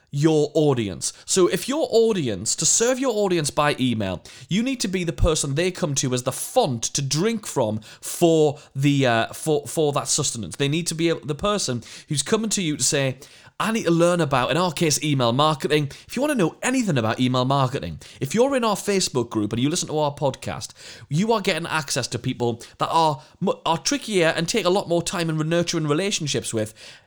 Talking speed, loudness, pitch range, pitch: 215 wpm, -22 LUFS, 130-180 Hz, 155 Hz